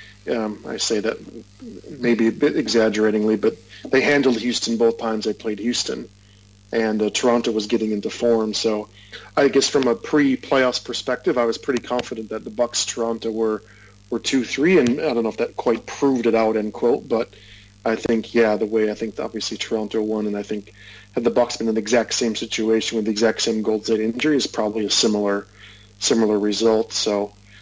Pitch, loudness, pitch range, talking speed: 110 Hz, -21 LUFS, 105-115 Hz, 200 wpm